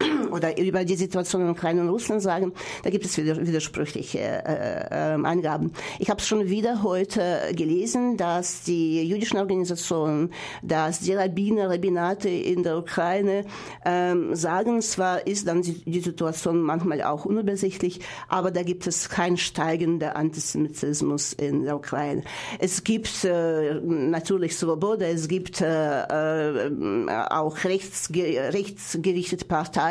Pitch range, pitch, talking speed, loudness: 160-190 Hz, 175 Hz, 130 wpm, -25 LUFS